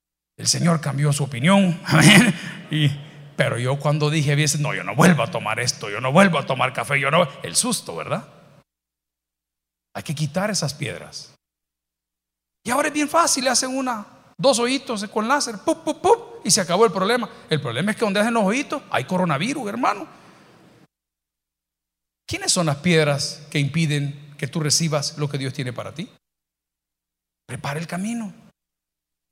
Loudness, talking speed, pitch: -20 LUFS, 170 wpm, 150 Hz